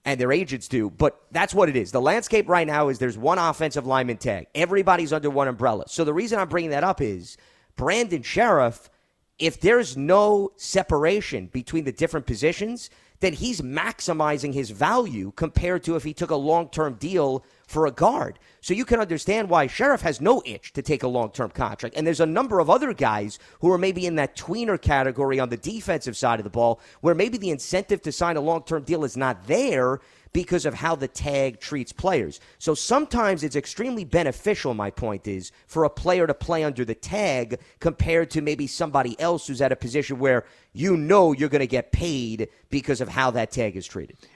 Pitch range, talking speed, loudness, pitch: 130-170 Hz, 210 wpm, -23 LUFS, 150 Hz